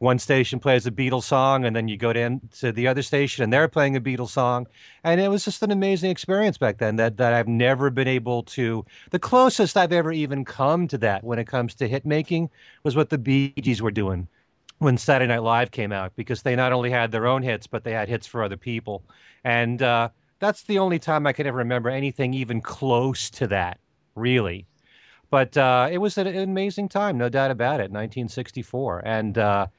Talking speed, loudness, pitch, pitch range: 220 wpm, -23 LUFS, 125 Hz, 115-145 Hz